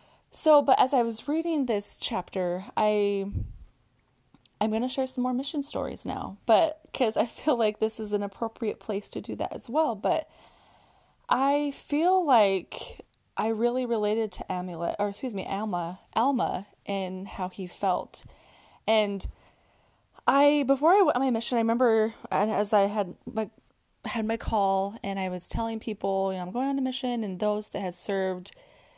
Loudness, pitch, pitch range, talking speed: -27 LUFS, 220 Hz, 195-255 Hz, 175 wpm